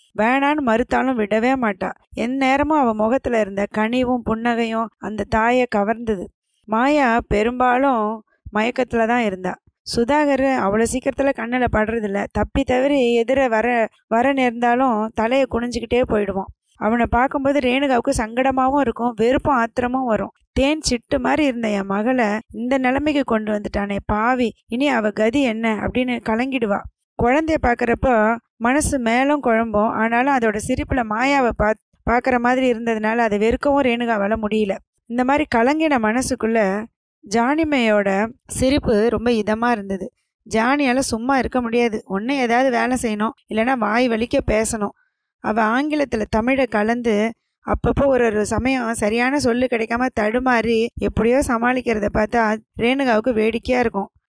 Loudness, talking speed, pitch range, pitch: -19 LUFS, 125 wpm, 220-260 Hz, 235 Hz